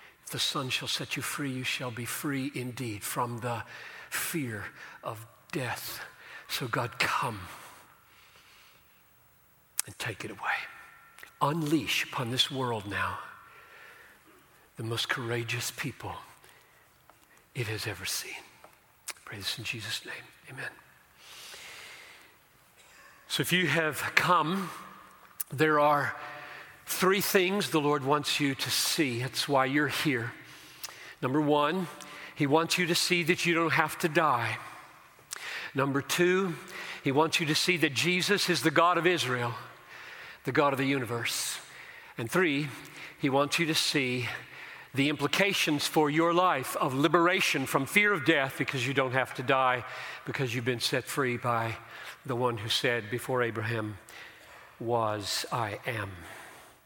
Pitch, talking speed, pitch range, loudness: 140 Hz, 140 wpm, 125-160 Hz, -29 LUFS